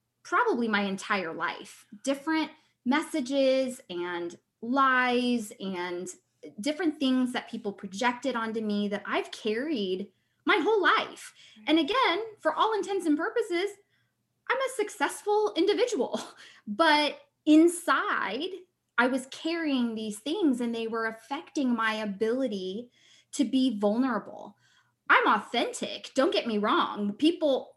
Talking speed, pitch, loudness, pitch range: 120 wpm, 265 Hz, -28 LUFS, 220-325 Hz